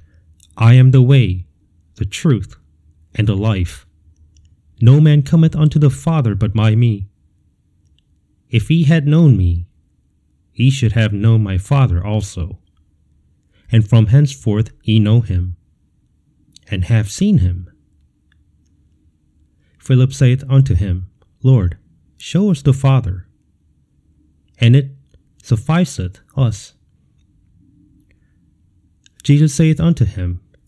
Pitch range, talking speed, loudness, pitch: 80-125 Hz, 115 wpm, -14 LUFS, 95 Hz